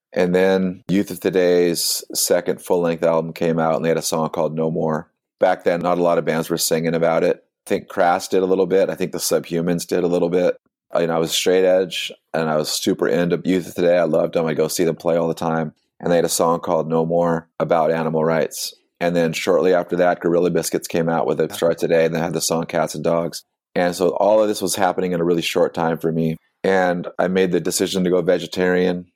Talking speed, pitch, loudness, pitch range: 255 wpm, 85 Hz, -19 LUFS, 80-90 Hz